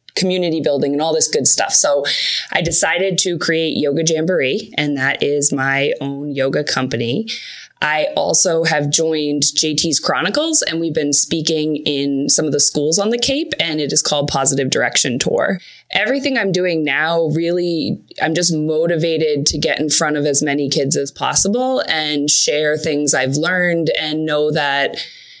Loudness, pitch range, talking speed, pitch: -16 LUFS, 145-170 Hz, 170 wpm, 155 Hz